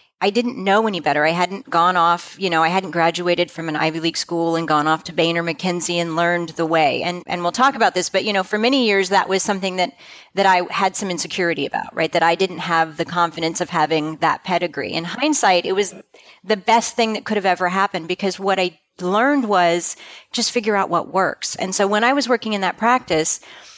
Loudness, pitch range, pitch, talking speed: -19 LUFS, 170-205 Hz, 180 Hz, 235 wpm